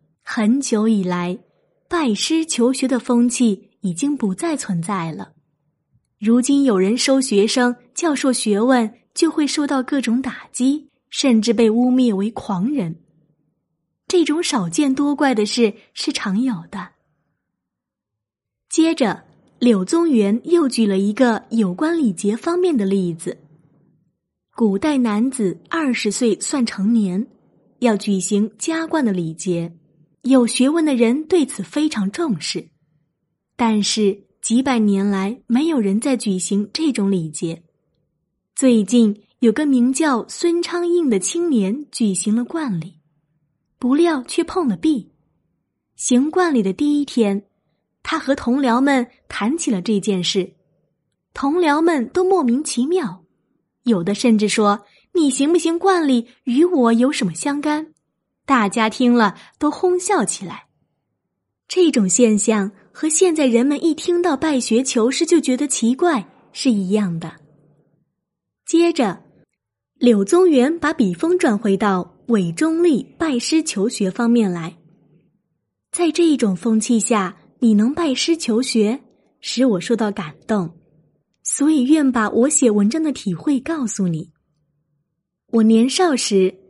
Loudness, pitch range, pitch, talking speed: -18 LUFS, 195-285 Hz, 235 Hz, 195 characters per minute